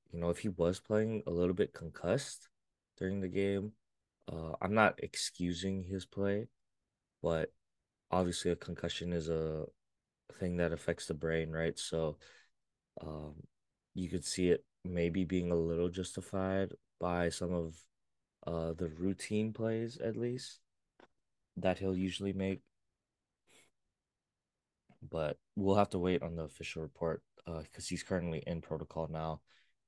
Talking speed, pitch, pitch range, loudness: 145 wpm, 90 Hz, 80-95 Hz, -37 LUFS